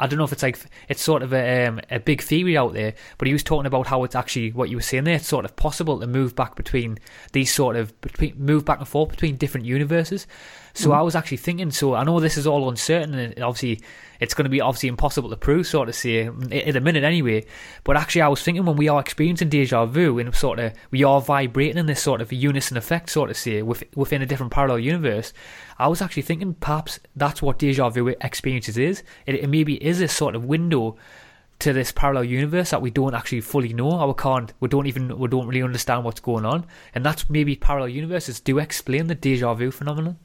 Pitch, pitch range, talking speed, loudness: 140 Hz, 125-150 Hz, 240 wpm, -22 LUFS